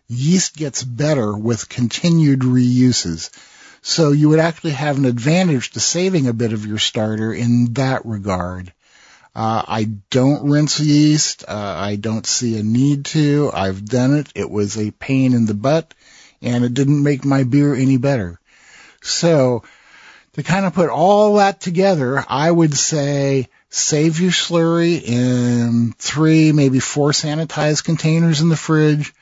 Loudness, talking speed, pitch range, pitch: -16 LUFS, 155 wpm, 120-155 Hz, 140 Hz